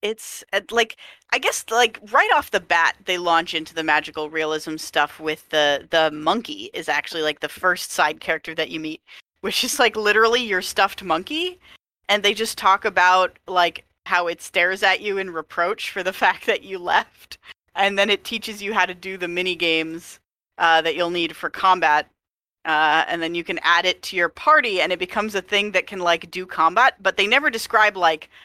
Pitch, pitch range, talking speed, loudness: 185 Hz, 165-210 Hz, 205 wpm, -20 LUFS